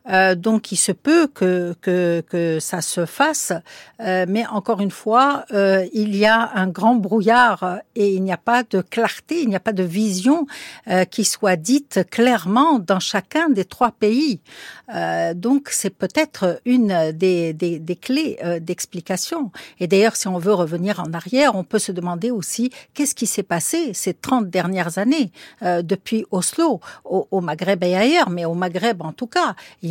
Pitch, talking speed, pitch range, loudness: 200 Hz, 185 wpm, 180-245 Hz, -19 LUFS